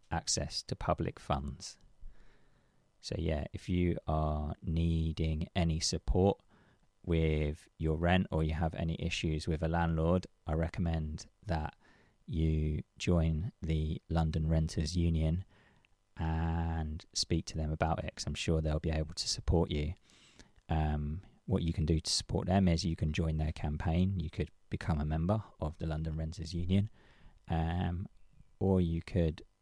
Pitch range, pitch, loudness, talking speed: 80-90 Hz, 80 Hz, -34 LUFS, 150 wpm